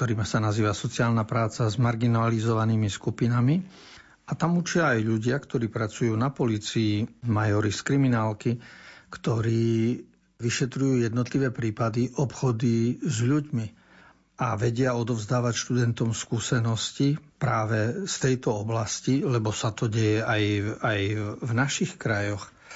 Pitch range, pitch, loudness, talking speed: 110-130 Hz, 120 Hz, -26 LUFS, 120 wpm